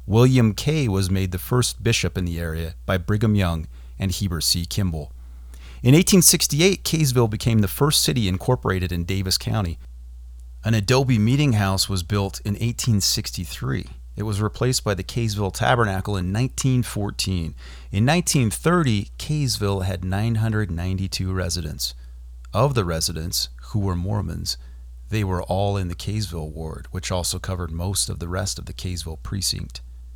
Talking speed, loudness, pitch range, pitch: 150 wpm, -22 LUFS, 85-115 Hz, 95 Hz